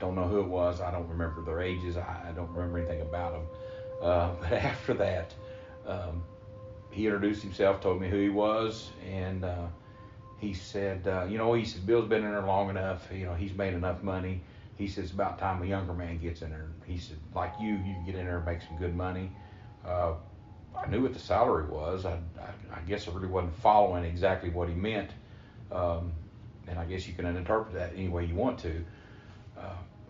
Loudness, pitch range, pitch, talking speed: -32 LUFS, 85-105 Hz, 95 Hz, 215 wpm